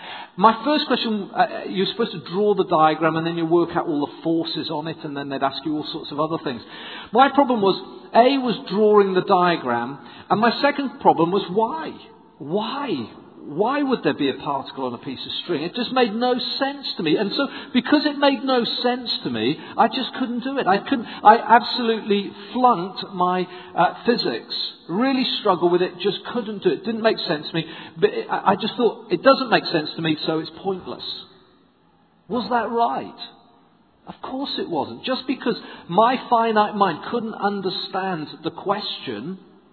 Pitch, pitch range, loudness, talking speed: 205 Hz, 175-245 Hz, -21 LUFS, 195 wpm